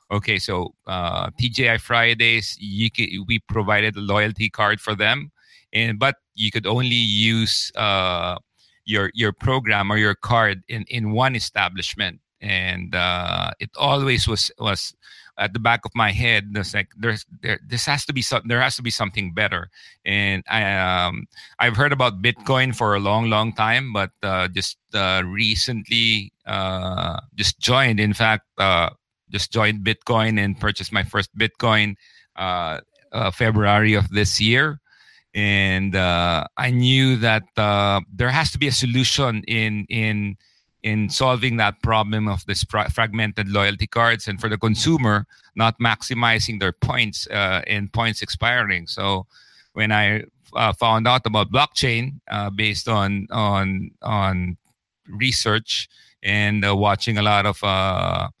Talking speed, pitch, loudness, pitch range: 155 wpm, 110 Hz, -20 LUFS, 100-115 Hz